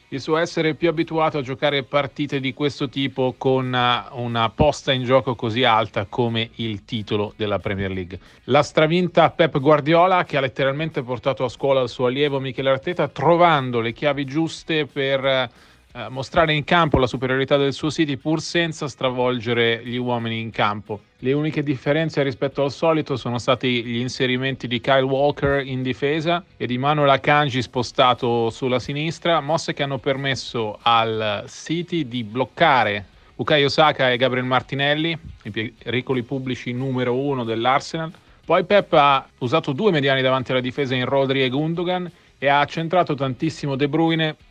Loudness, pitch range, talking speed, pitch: -21 LUFS, 125-150 Hz, 160 wpm, 135 Hz